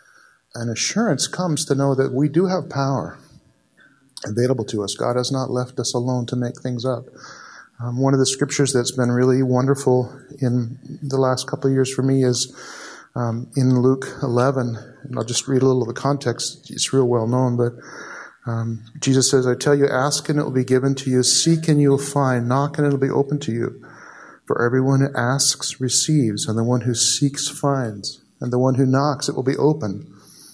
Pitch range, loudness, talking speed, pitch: 125-140 Hz, -20 LUFS, 205 wpm, 130 Hz